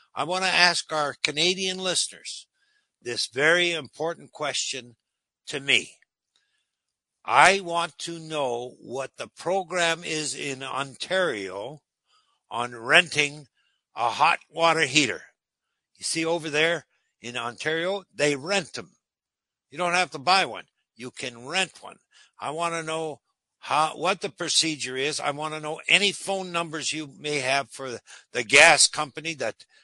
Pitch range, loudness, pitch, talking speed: 145-175 Hz, -24 LUFS, 160 Hz, 145 wpm